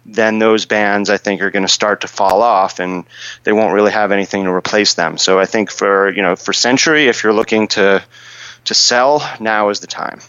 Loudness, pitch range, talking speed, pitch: -13 LUFS, 95-110 Hz, 225 wpm, 100 Hz